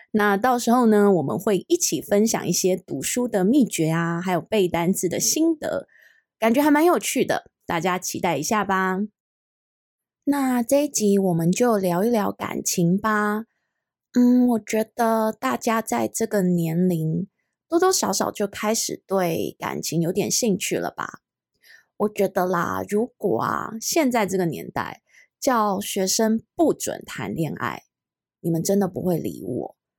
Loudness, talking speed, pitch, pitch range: -22 LUFS, 220 characters per minute, 210 Hz, 185-240 Hz